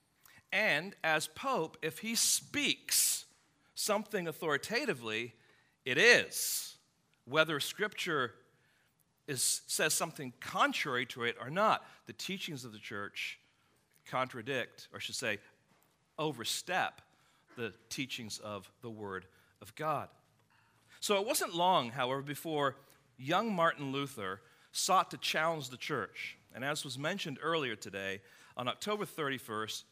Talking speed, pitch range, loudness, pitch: 120 wpm, 115-165 Hz, -34 LUFS, 140 Hz